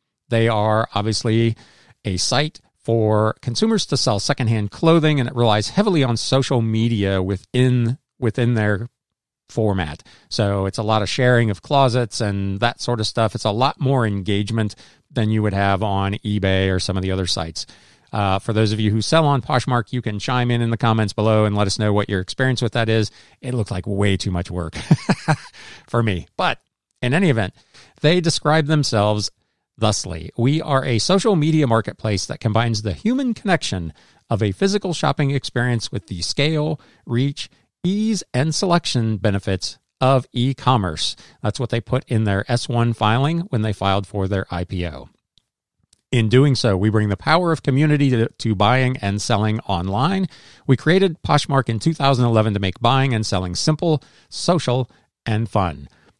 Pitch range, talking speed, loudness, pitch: 105-135 Hz, 175 wpm, -20 LUFS, 115 Hz